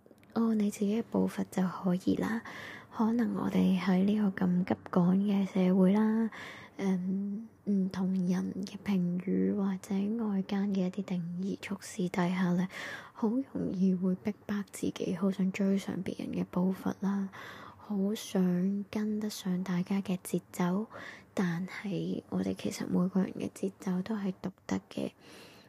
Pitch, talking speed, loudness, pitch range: 195 Hz, 215 characters per minute, -32 LUFS, 185-205 Hz